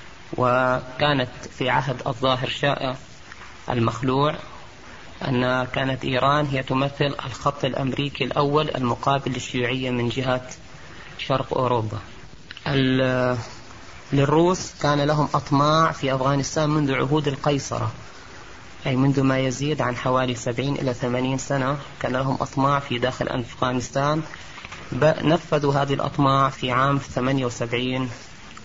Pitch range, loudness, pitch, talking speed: 125-140 Hz, -23 LUFS, 130 Hz, 105 wpm